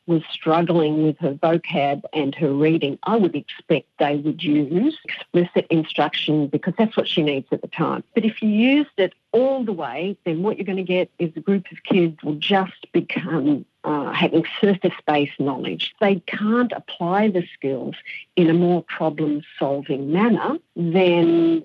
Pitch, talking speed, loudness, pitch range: 170 Hz, 170 wpm, -21 LUFS, 155-200 Hz